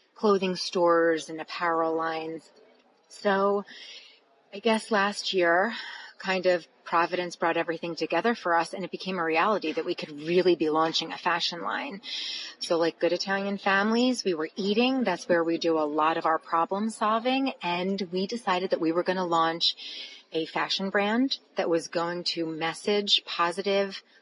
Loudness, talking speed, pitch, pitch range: -27 LUFS, 170 wpm, 180 Hz, 165-200 Hz